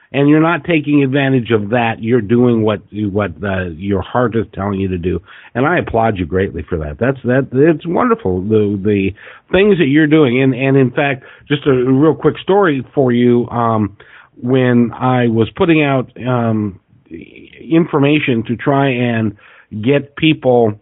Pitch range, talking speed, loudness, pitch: 105-140 Hz, 175 wpm, -14 LUFS, 125 Hz